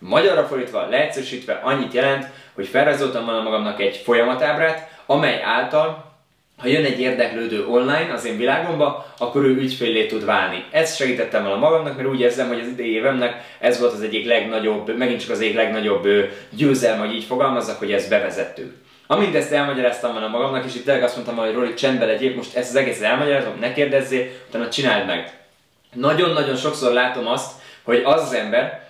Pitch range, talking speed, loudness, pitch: 120-140 Hz, 175 wpm, -20 LUFS, 125 Hz